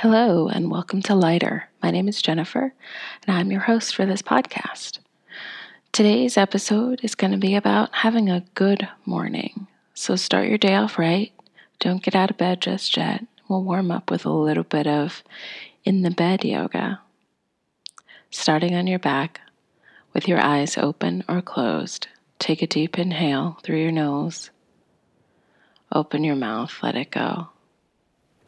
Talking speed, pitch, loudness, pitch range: 160 wpm, 190 Hz, -22 LUFS, 170-215 Hz